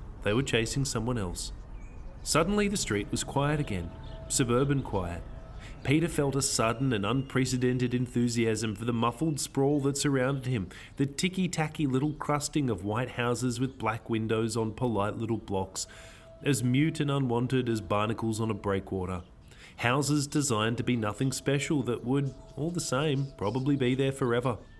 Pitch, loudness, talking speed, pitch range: 125 Hz, -29 LUFS, 160 wpm, 110-140 Hz